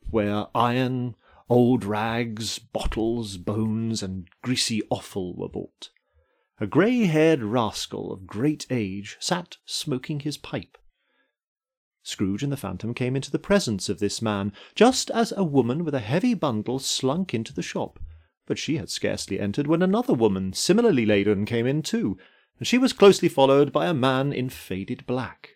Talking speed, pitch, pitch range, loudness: 160 wpm, 125 Hz, 105-155 Hz, -24 LUFS